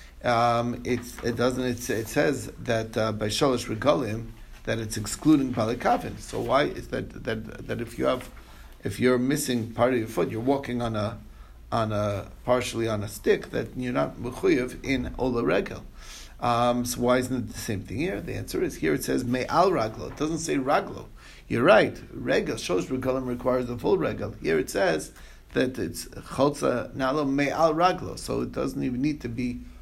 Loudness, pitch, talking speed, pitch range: -26 LUFS, 120 Hz, 190 wpm, 110-130 Hz